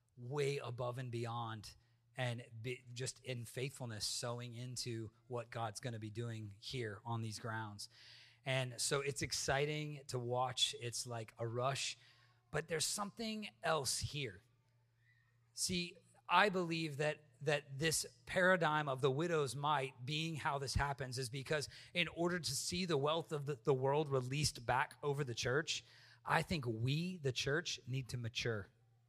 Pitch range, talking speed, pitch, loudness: 120-150 Hz, 155 wpm, 130 Hz, -40 LUFS